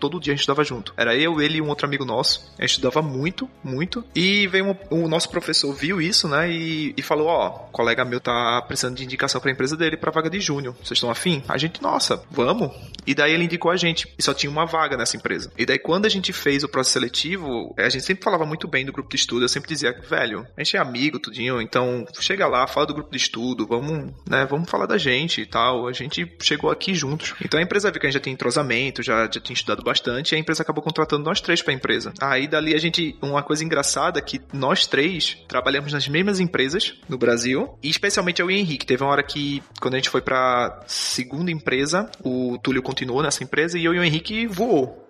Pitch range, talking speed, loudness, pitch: 130-165 Hz, 245 wpm, -22 LUFS, 145 Hz